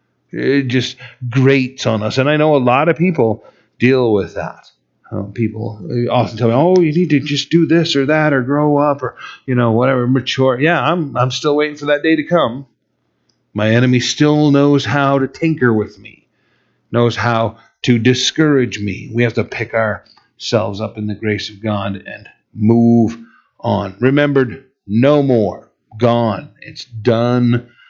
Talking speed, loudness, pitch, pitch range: 175 wpm, -15 LUFS, 125 Hz, 115-145 Hz